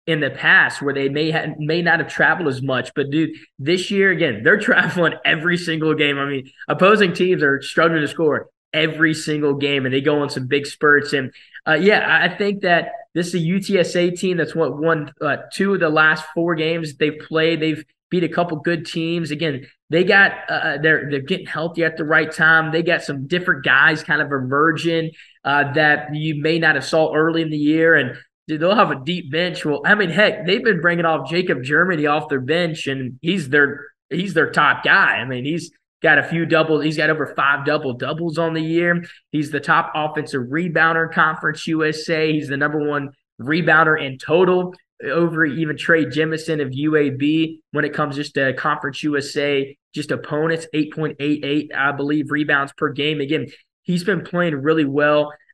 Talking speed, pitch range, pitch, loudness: 200 wpm, 145-165 Hz, 155 Hz, -18 LUFS